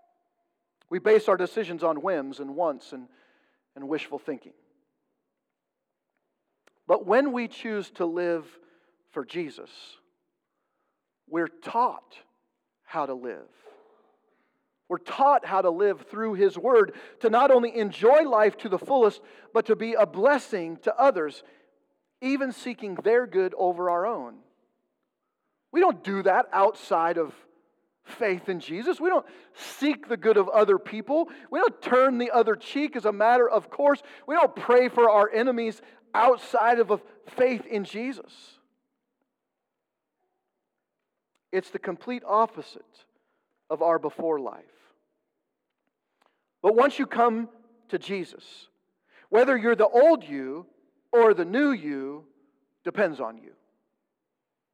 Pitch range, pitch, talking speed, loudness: 185-275 Hz, 225 Hz, 130 wpm, -24 LUFS